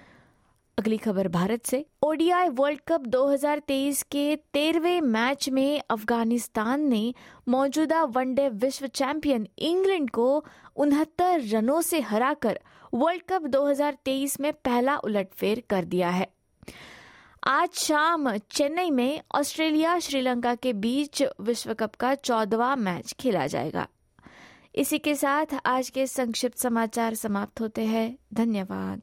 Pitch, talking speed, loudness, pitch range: 265 Hz, 120 wpm, -26 LUFS, 230-295 Hz